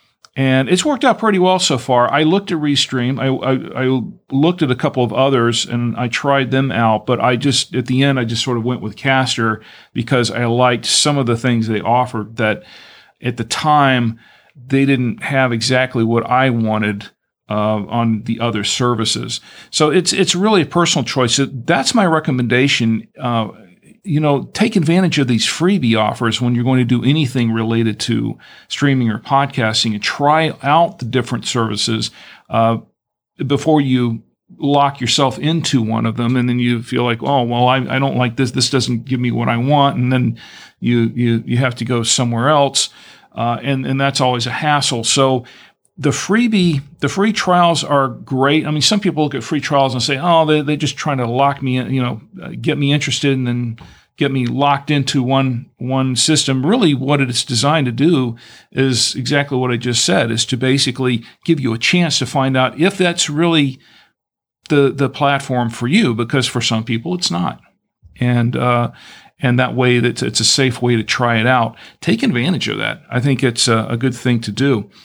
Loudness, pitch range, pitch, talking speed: -16 LUFS, 120-145 Hz, 130 Hz, 195 wpm